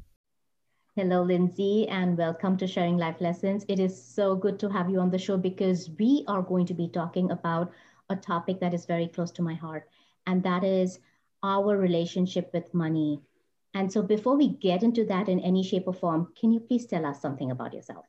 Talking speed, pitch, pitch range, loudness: 205 wpm, 185 Hz, 170-195 Hz, -28 LUFS